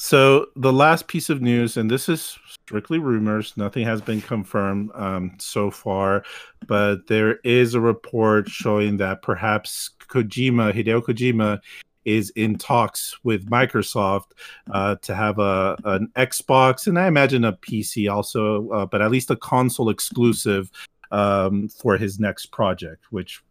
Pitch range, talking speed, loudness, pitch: 100-125 Hz, 150 wpm, -21 LUFS, 110 Hz